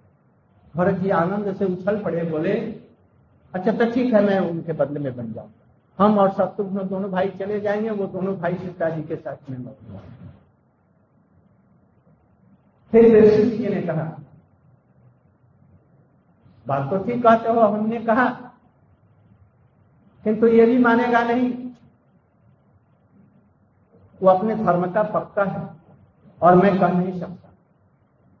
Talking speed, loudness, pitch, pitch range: 125 wpm, -20 LUFS, 190 Hz, 155-215 Hz